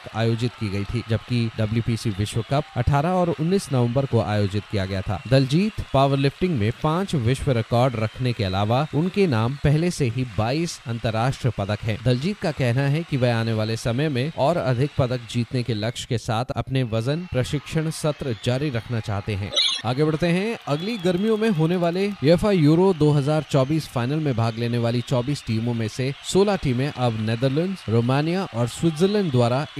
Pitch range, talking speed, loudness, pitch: 115-155 Hz, 180 wpm, -23 LUFS, 130 Hz